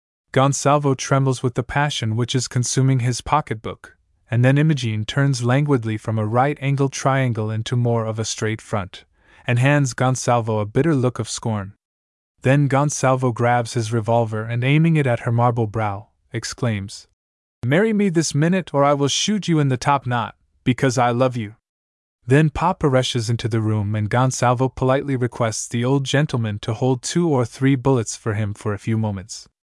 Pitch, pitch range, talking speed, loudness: 125 Hz, 110-135 Hz, 180 wpm, -20 LUFS